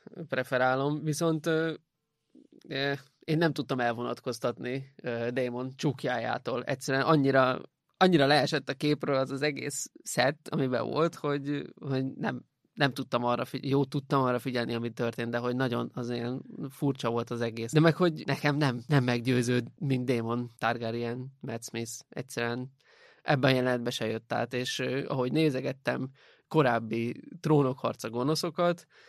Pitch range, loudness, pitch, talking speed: 120-145 Hz, -30 LUFS, 130 Hz, 140 wpm